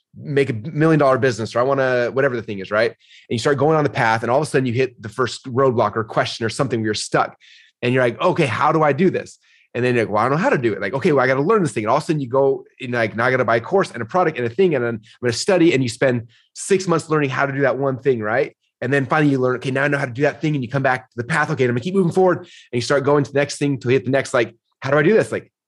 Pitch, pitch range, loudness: 135 Hz, 120-145 Hz, -19 LUFS